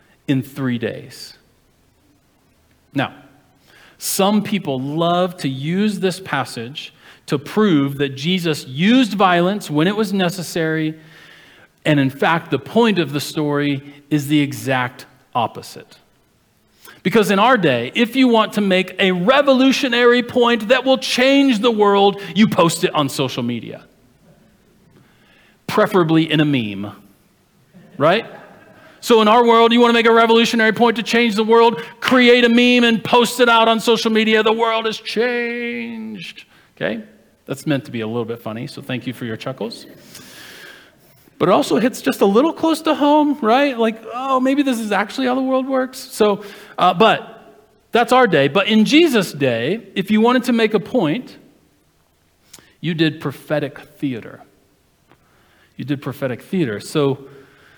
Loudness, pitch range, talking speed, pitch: -16 LUFS, 150-235 Hz, 160 wpm, 205 Hz